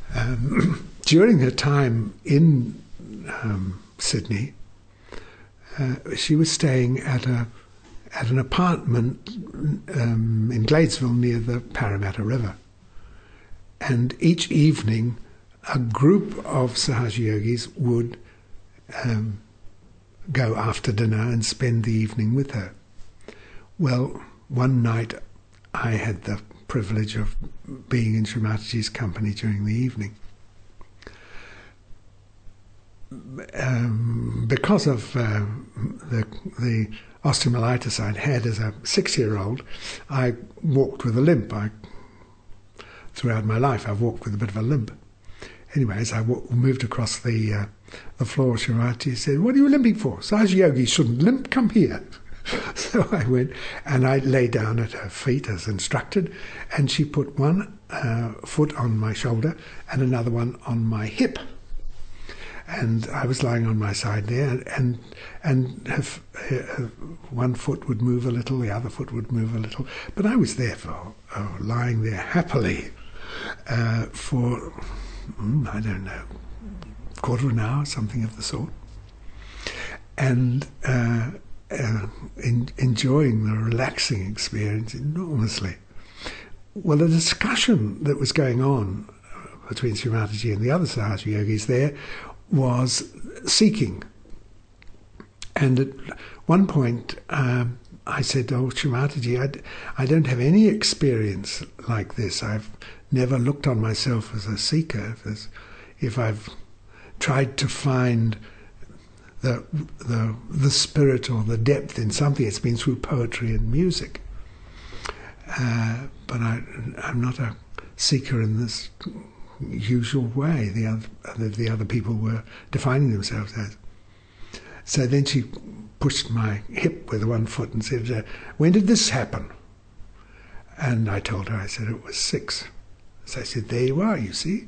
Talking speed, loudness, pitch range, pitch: 140 wpm, -24 LUFS, 105-135 Hz, 120 Hz